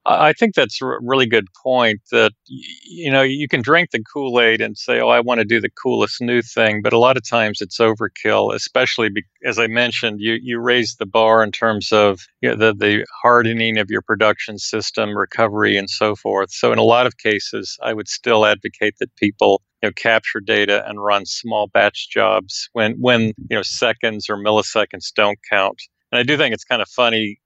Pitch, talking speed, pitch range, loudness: 115 Hz, 210 wpm, 105-120 Hz, -17 LUFS